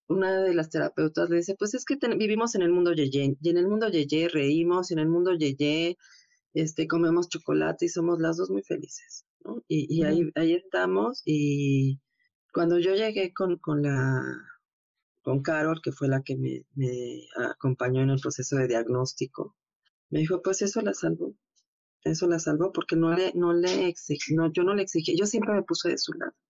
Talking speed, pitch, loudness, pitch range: 210 wpm, 165 Hz, -27 LUFS, 140-185 Hz